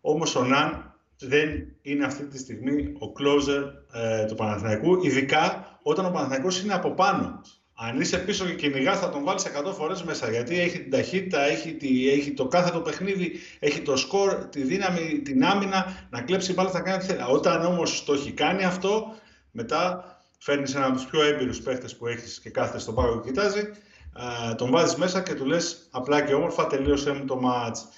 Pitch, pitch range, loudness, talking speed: 145 Hz, 130-185 Hz, -25 LUFS, 195 wpm